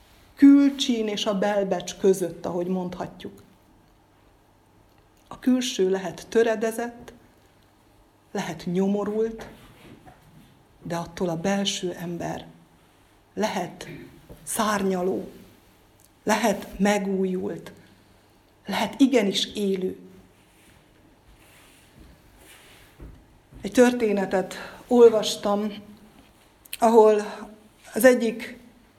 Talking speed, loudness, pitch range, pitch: 65 wpm, -23 LUFS, 175-220 Hz, 200 Hz